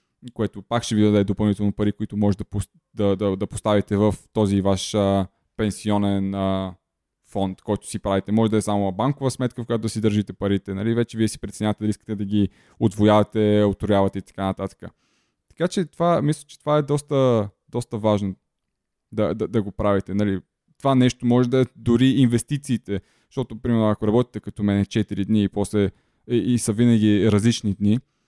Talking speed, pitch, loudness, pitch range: 190 wpm, 105 Hz, -22 LUFS, 100-120 Hz